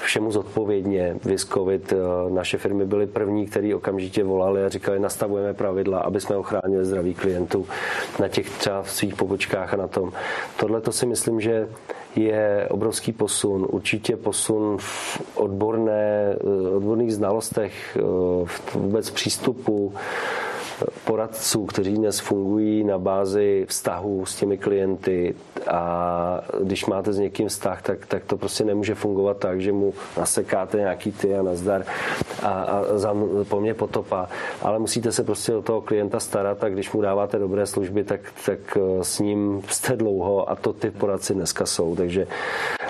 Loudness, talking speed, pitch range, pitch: -24 LUFS, 150 wpm, 95-105 Hz, 100 Hz